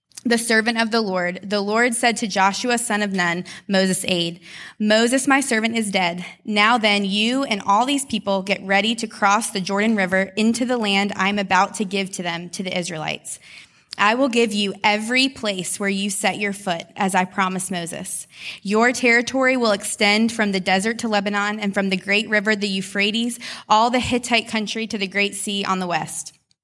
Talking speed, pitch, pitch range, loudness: 200 wpm, 205 Hz, 190-225 Hz, -20 LUFS